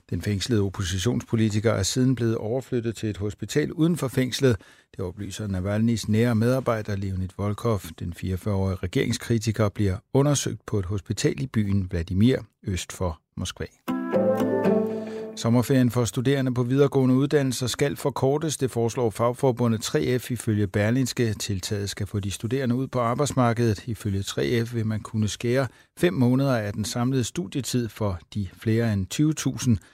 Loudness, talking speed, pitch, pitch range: -25 LUFS, 145 wpm, 115 Hz, 105-130 Hz